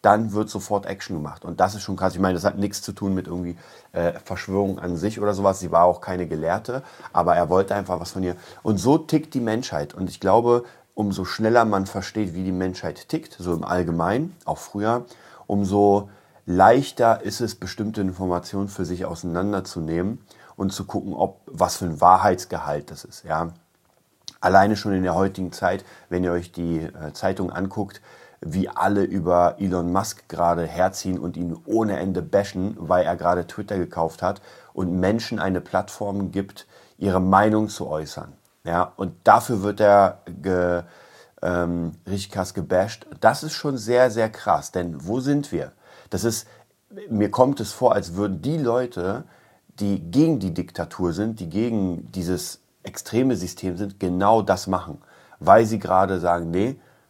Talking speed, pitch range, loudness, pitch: 175 wpm, 90-105 Hz, -23 LUFS, 95 Hz